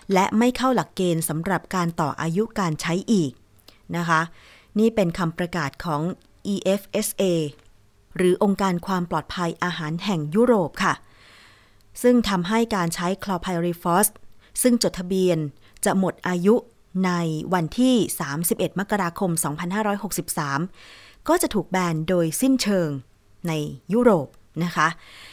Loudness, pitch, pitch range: -23 LUFS, 175 Hz, 160-200 Hz